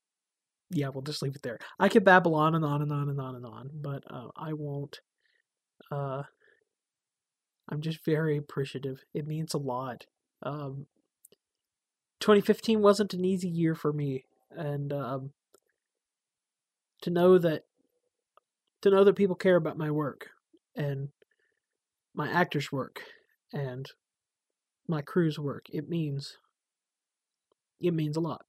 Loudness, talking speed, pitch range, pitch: -29 LUFS, 140 wpm, 145-200 Hz, 155 Hz